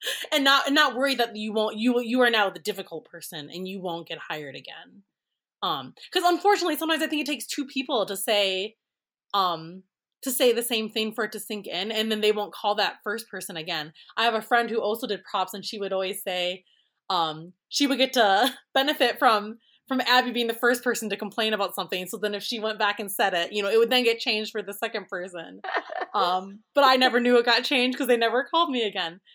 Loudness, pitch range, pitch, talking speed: -25 LUFS, 200-250 Hz, 220 Hz, 240 wpm